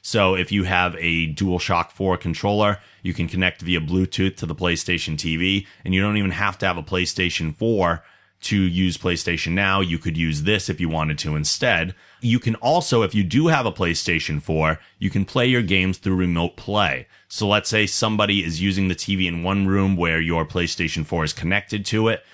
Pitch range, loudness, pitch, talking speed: 85-100 Hz, -21 LUFS, 95 Hz, 205 wpm